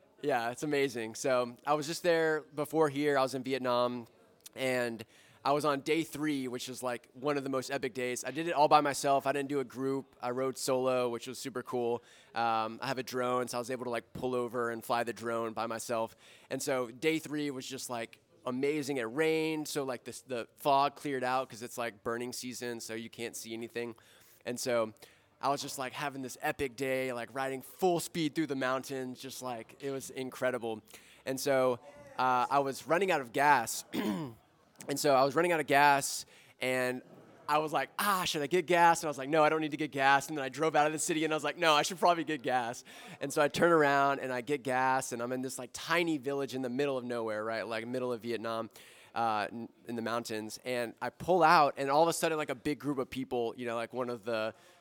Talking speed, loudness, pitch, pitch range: 240 wpm, -32 LUFS, 130 Hz, 120-145 Hz